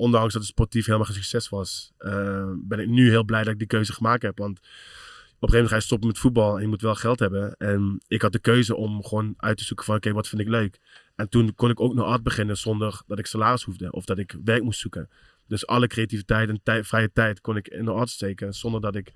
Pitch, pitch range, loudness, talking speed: 110 Hz, 105-115 Hz, -24 LUFS, 275 wpm